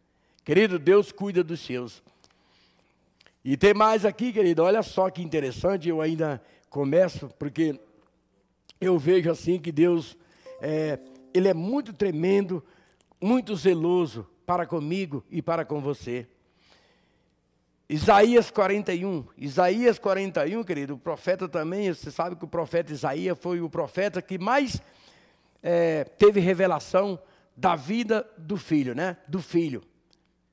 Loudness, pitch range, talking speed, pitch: -25 LUFS, 155-195 Hz, 130 wpm, 175 Hz